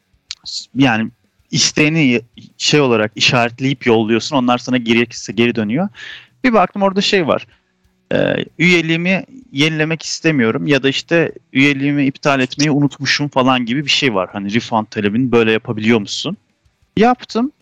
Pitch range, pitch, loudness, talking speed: 115-155 Hz, 135 Hz, -15 LUFS, 130 wpm